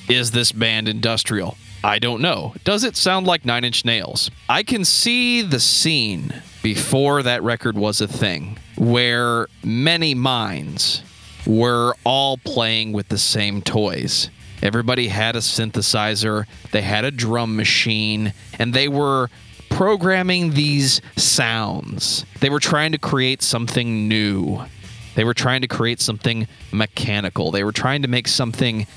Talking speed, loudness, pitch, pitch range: 145 wpm, -18 LUFS, 120 Hz, 110-135 Hz